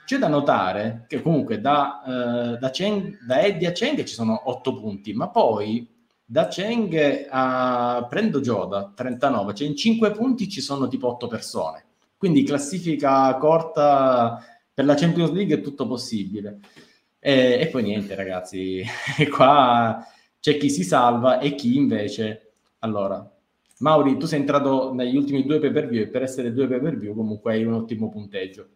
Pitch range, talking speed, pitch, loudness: 115-145 Hz, 165 wpm, 130 Hz, -22 LUFS